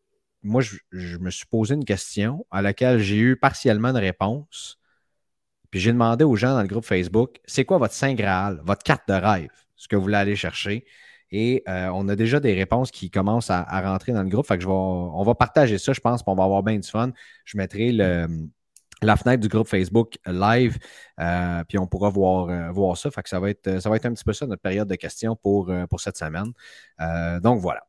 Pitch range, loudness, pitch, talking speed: 95-120 Hz, -23 LUFS, 100 Hz, 235 wpm